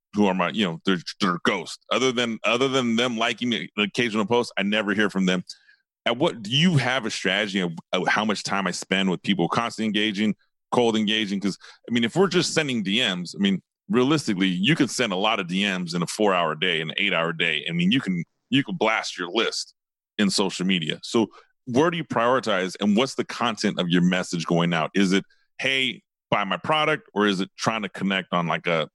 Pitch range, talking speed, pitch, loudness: 95-135 Hz, 225 wpm, 110 Hz, -23 LUFS